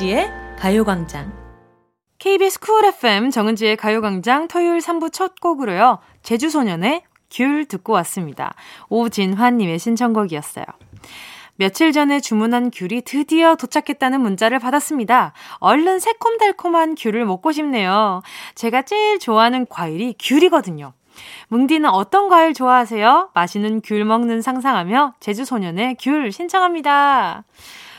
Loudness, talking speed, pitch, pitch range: -17 LUFS, 305 characters per minute, 250 Hz, 215-315 Hz